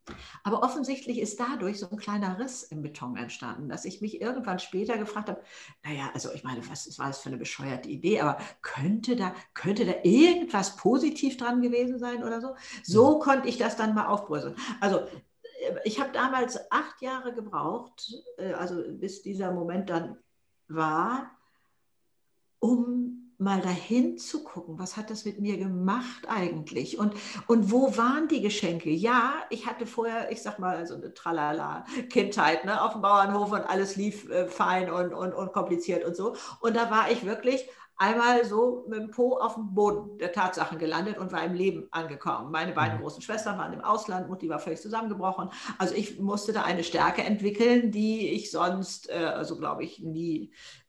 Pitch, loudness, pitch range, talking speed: 210 Hz, -29 LUFS, 180-240 Hz, 180 wpm